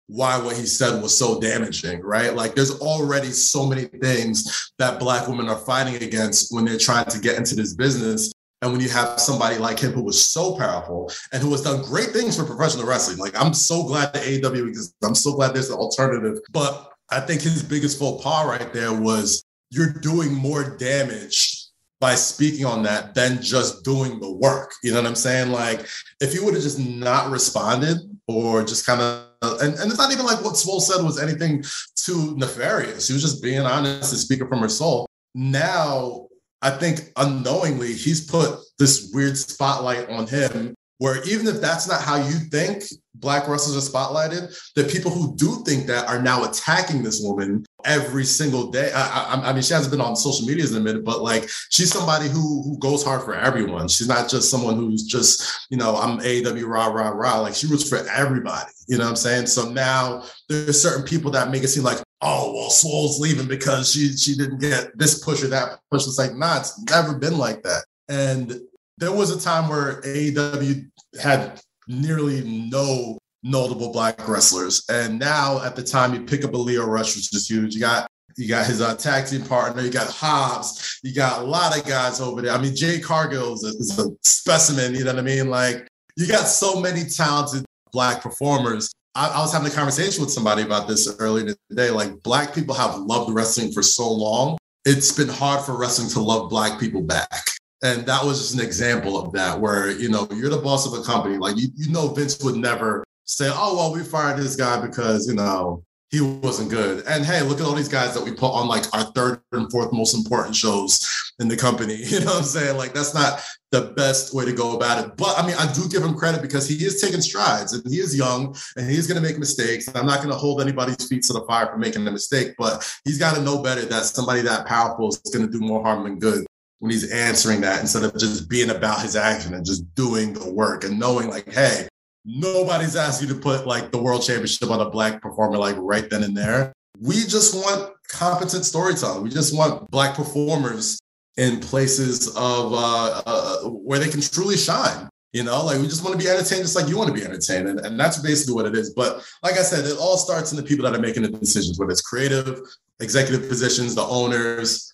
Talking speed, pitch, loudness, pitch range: 220 wpm, 130 Hz, -21 LUFS, 115-145 Hz